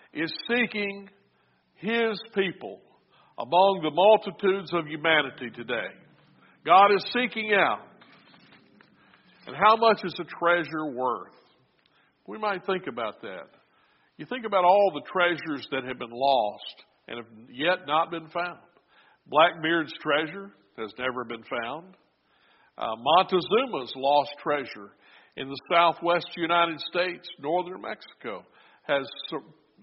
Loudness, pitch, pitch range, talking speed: -25 LUFS, 170 Hz, 145-190 Hz, 125 wpm